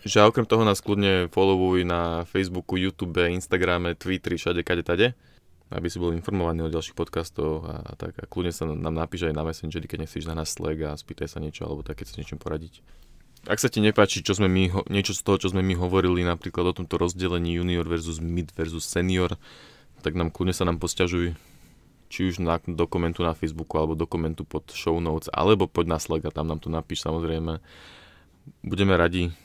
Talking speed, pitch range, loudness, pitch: 205 wpm, 80-95 Hz, -26 LUFS, 85 Hz